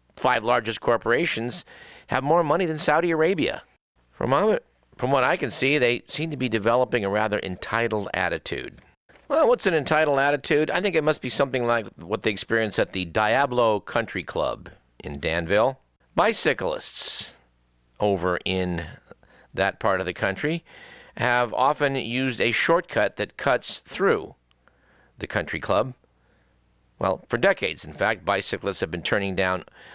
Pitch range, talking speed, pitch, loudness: 95-140 Hz, 150 wpm, 115 Hz, -24 LUFS